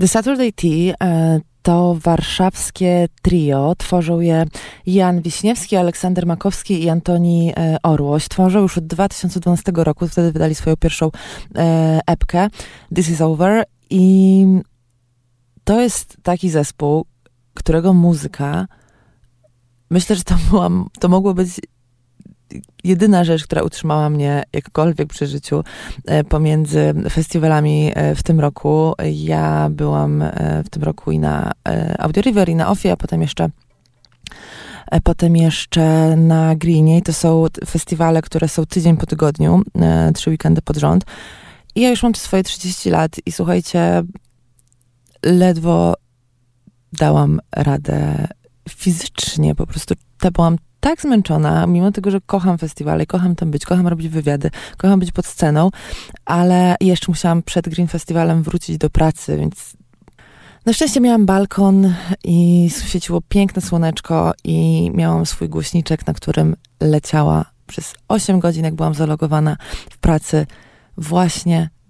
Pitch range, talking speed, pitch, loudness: 145-180 Hz, 140 wpm, 165 Hz, -16 LUFS